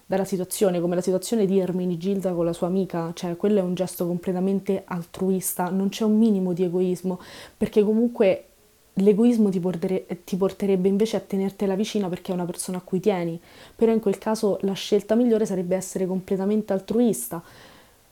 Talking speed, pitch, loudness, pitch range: 180 wpm, 190 Hz, -24 LUFS, 185-205 Hz